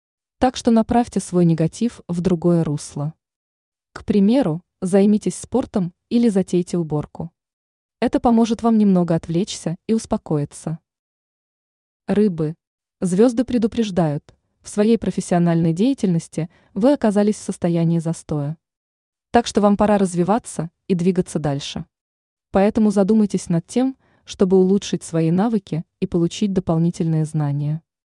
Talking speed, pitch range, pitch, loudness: 115 wpm, 165-215 Hz, 190 Hz, -20 LUFS